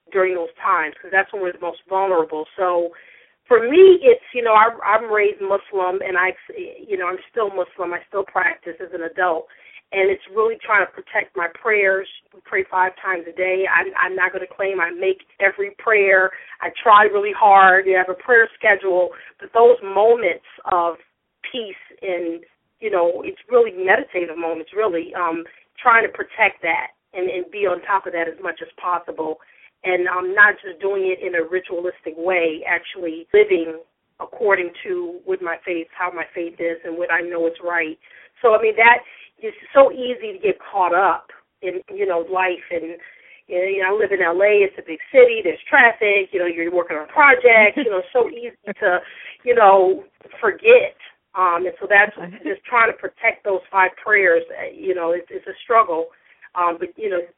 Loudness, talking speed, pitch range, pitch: -18 LUFS, 195 wpm, 175-225 Hz, 190 Hz